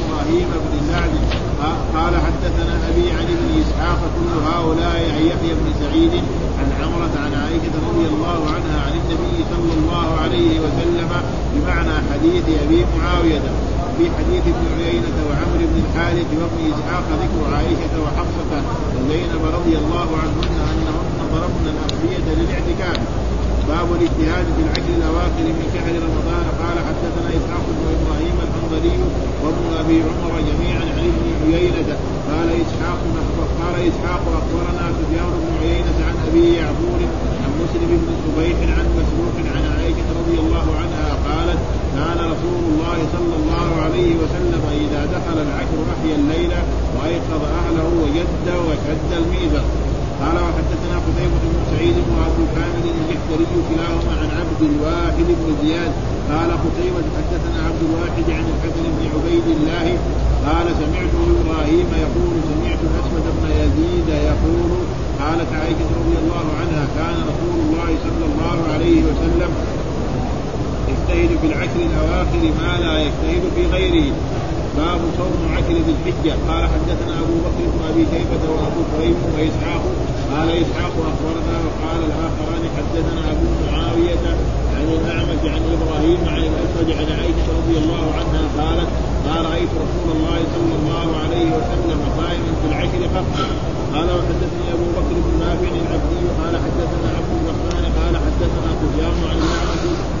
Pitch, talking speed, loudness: 170 Hz, 135 wpm, -19 LUFS